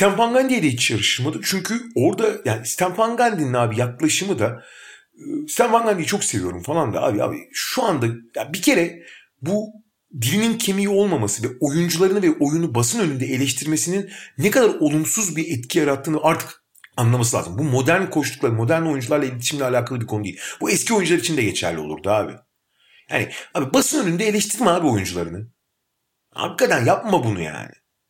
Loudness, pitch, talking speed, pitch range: -20 LUFS, 160 Hz, 155 wpm, 125-200 Hz